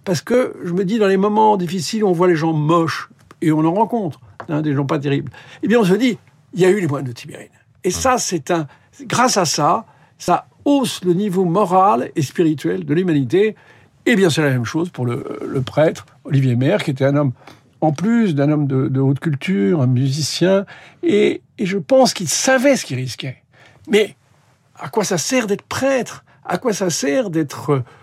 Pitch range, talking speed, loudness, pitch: 140-200 Hz, 215 wpm, -17 LUFS, 170 Hz